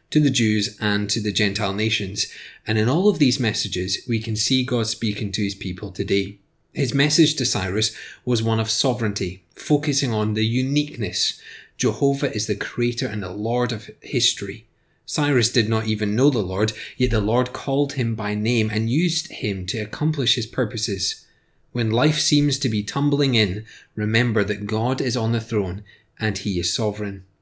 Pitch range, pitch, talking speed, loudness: 105-130 Hz, 115 Hz, 180 wpm, -21 LUFS